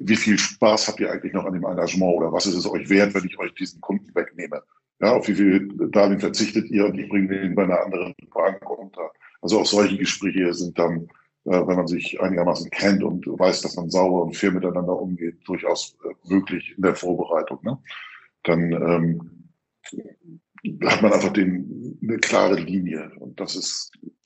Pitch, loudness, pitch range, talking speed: 90 Hz, -22 LUFS, 85-100 Hz, 190 wpm